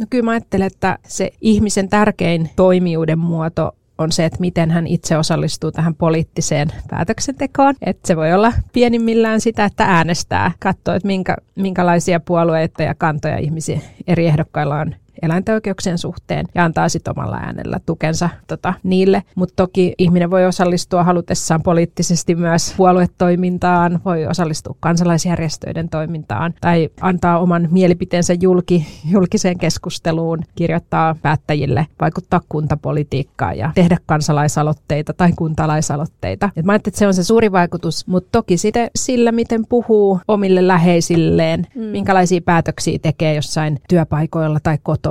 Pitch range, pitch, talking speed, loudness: 160-185 Hz, 175 Hz, 135 wpm, -16 LUFS